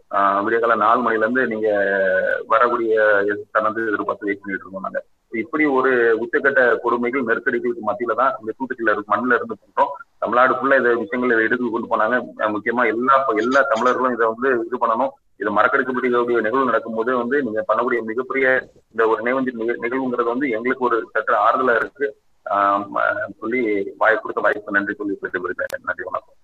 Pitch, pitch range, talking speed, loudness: 115 Hz, 110-130 Hz, 150 wpm, -19 LUFS